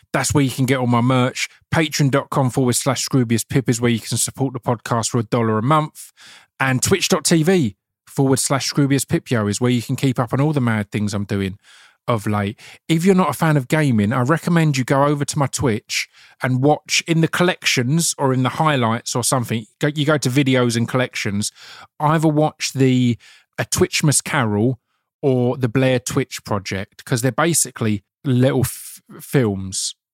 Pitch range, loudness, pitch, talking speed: 120-150 Hz, -19 LUFS, 130 Hz, 185 wpm